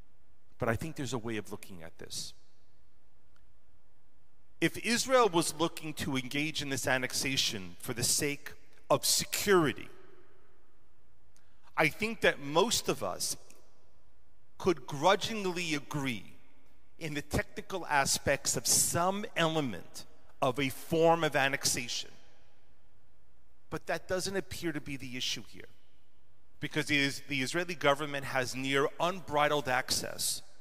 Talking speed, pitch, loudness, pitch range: 120 wpm, 140 Hz, -31 LUFS, 125-160 Hz